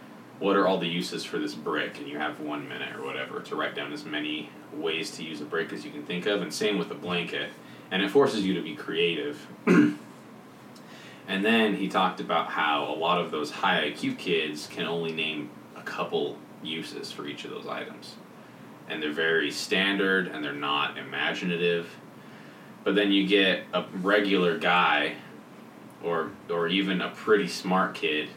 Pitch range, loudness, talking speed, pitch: 75-95 Hz, -27 LUFS, 185 wpm, 85 Hz